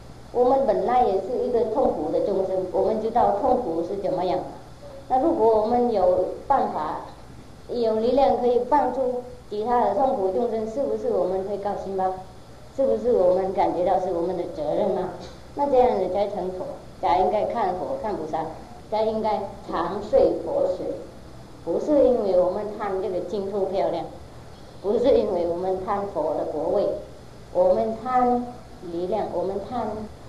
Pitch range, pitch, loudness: 185-255 Hz, 215 Hz, -24 LUFS